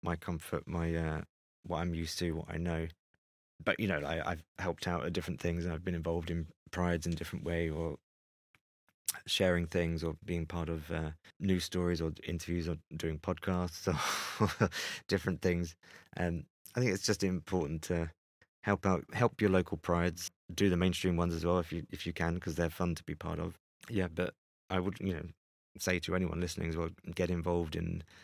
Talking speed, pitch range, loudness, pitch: 200 wpm, 80-90 Hz, -35 LUFS, 85 Hz